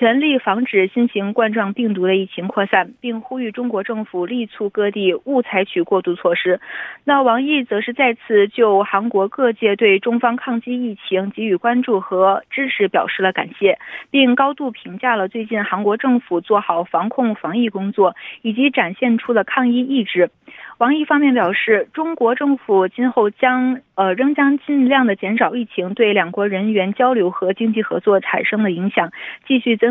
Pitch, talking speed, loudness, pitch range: 225 Hz, 275 characters per minute, -17 LUFS, 195-250 Hz